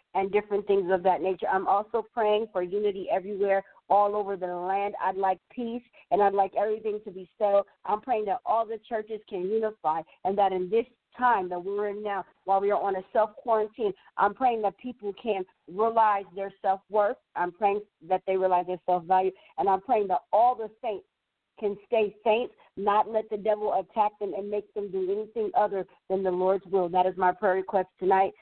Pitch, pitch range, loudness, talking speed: 200 Hz, 190-220 Hz, -28 LUFS, 210 wpm